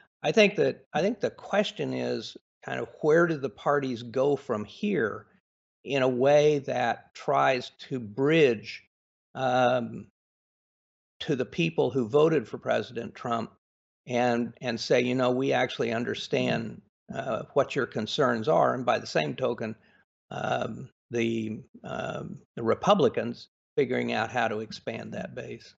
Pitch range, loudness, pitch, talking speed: 115-135 Hz, -27 LUFS, 125 Hz, 145 wpm